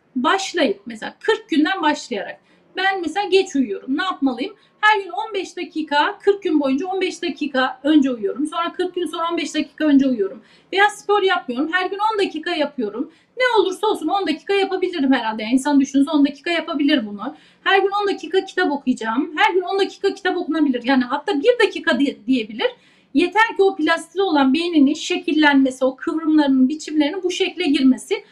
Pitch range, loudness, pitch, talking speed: 280-380 Hz, -19 LUFS, 325 Hz, 170 wpm